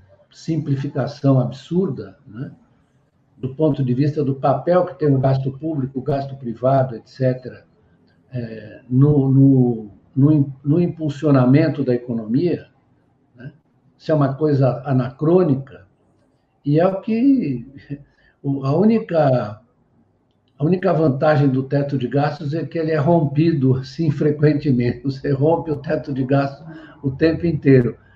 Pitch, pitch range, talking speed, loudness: 140 Hz, 130-155 Hz, 130 wpm, -19 LUFS